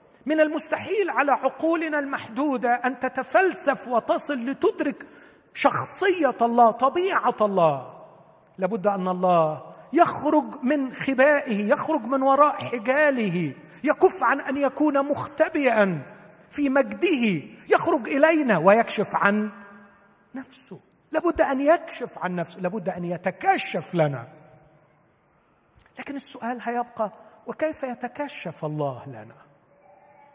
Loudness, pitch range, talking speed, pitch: -23 LUFS, 190-290 Hz, 100 wpm, 245 Hz